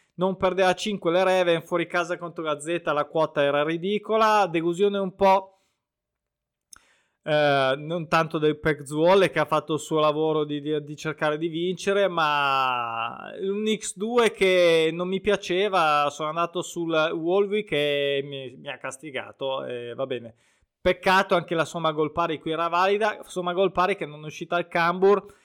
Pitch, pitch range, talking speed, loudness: 170 Hz, 150-190 Hz, 165 wpm, -24 LUFS